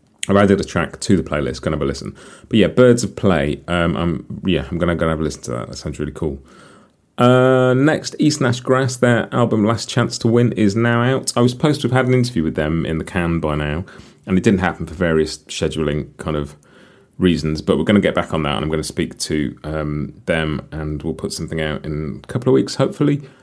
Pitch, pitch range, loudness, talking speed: 90 Hz, 75-120 Hz, -18 LUFS, 245 wpm